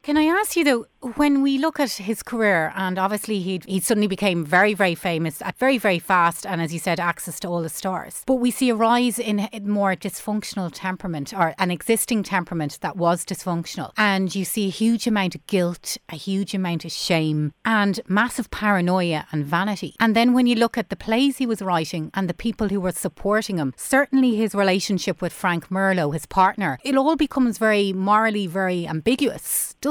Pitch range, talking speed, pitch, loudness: 175-225 Hz, 205 wpm, 195 Hz, -22 LUFS